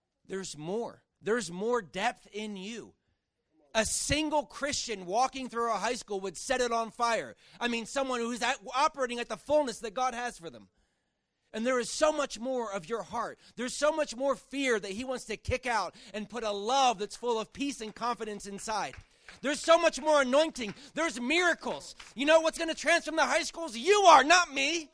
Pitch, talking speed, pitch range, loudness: 245 Hz, 205 wpm, 220-285 Hz, -30 LUFS